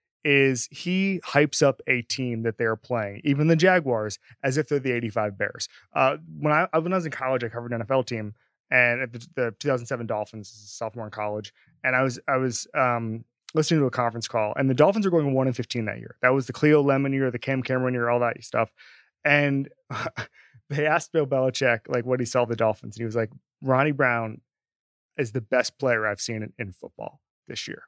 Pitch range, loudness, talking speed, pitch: 115-140 Hz, -25 LUFS, 220 wpm, 125 Hz